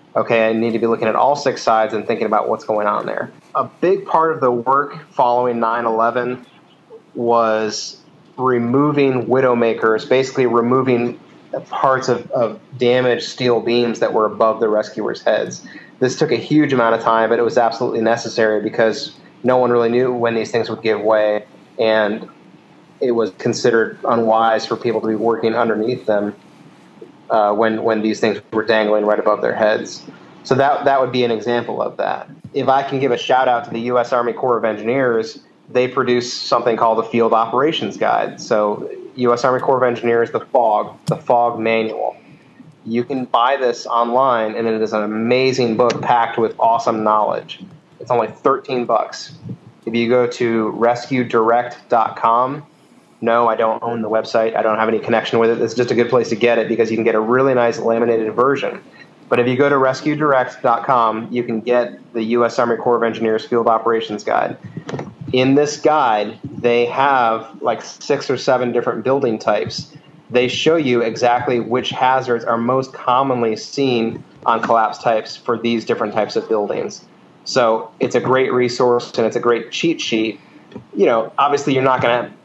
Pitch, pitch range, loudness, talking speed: 120 Hz, 115-125 Hz, -17 LUFS, 185 wpm